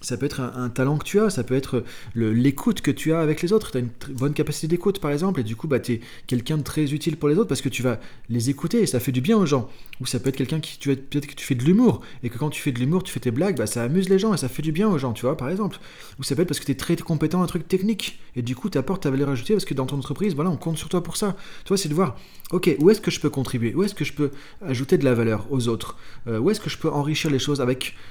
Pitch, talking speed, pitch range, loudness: 145 Hz, 350 wpm, 130-175 Hz, -23 LUFS